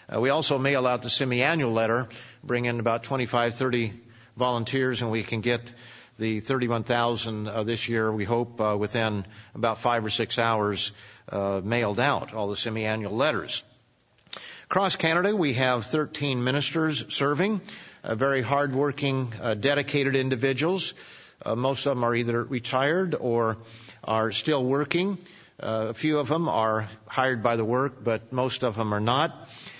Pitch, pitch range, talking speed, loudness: 120 Hz, 115-140 Hz, 160 wpm, -26 LUFS